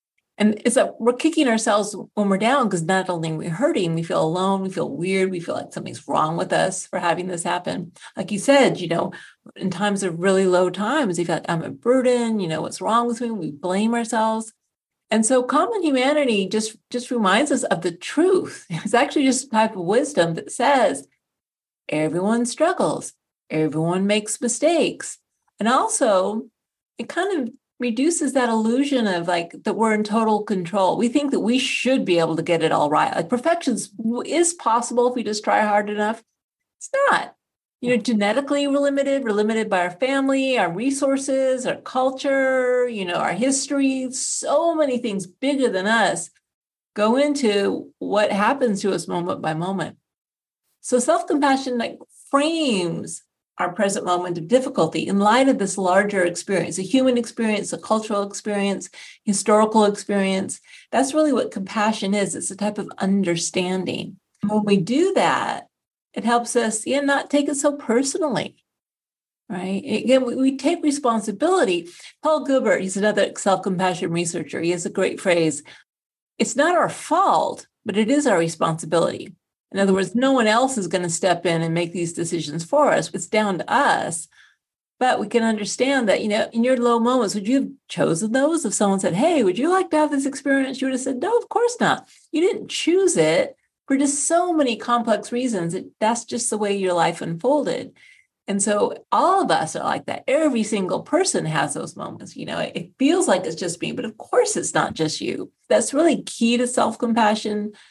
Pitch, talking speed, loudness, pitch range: 225 Hz, 185 wpm, -21 LUFS, 195-270 Hz